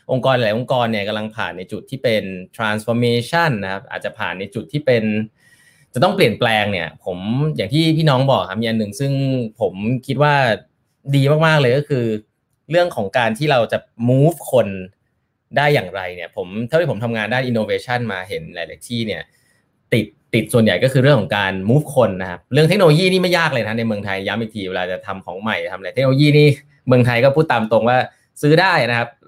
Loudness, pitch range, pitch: -17 LUFS, 110-145 Hz, 120 Hz